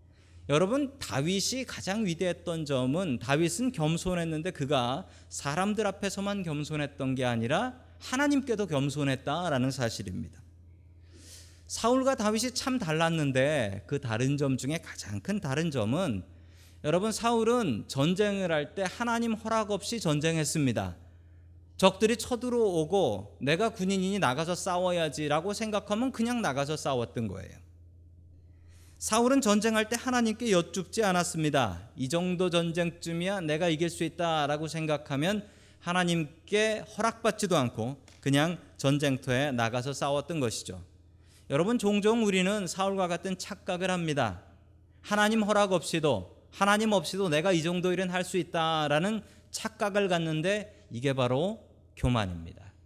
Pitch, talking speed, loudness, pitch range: 165 Hz, 305 characters per minute, -29 LUFS, 125-200 Hz